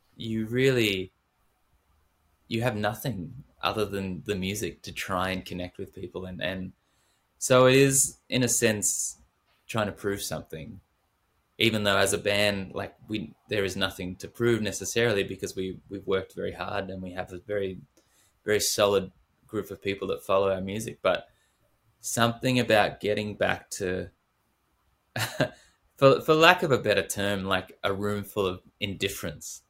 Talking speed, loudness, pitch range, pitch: 160 wpm, -27 LUFS, 95-110 Hz, 100 Hz